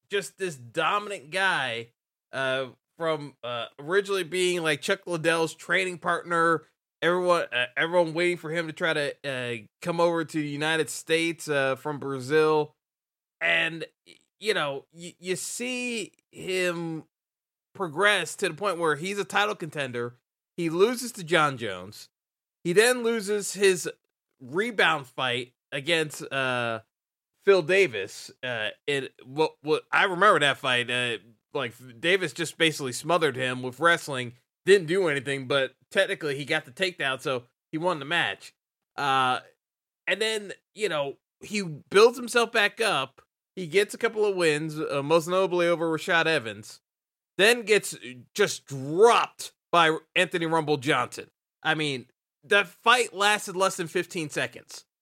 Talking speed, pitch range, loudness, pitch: 150 wpm, 140-190 Hz, -26 LUFS, 165 Hz